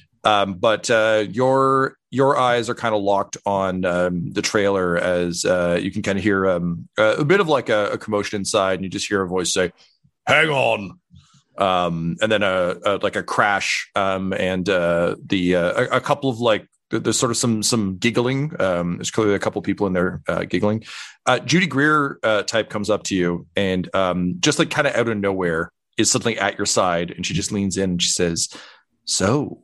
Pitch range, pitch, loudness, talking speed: 90-115 Hz, 100 Hz, -20 LUFS, 220 wpm